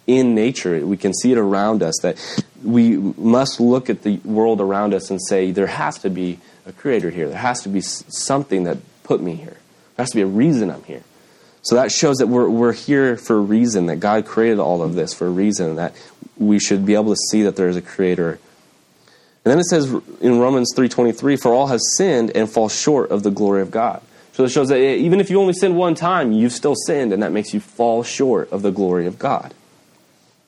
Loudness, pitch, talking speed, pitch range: -18 LUFS, 110 Hz, 230 wpm, 100-125 Hz